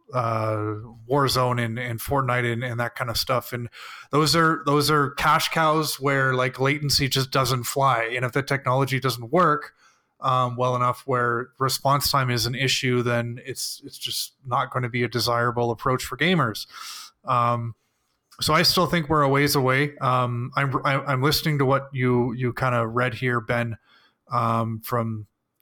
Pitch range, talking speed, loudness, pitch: 120-140 Hz, 180 wpm, -23 LUFS, 125 Hz